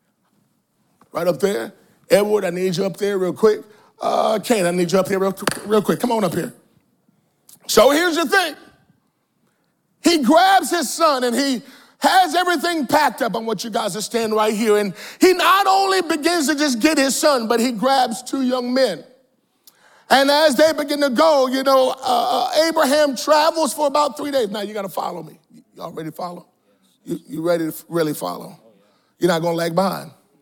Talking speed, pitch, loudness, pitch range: 195 wpm, 260 Hz, -18 LUFS, 210-310 Hz